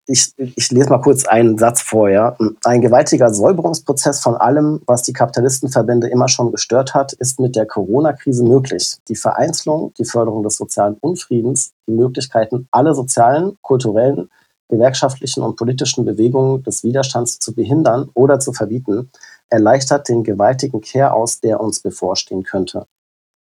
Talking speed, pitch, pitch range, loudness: 145 wpm, 125 Hz, 115-140 Hz, -15 LUFS